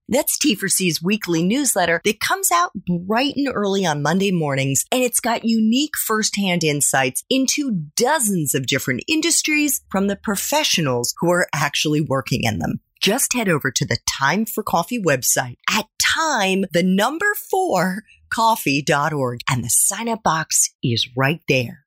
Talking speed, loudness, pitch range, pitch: 155 wpm, -19 LUFS, 150-240 Hz, 195 Hz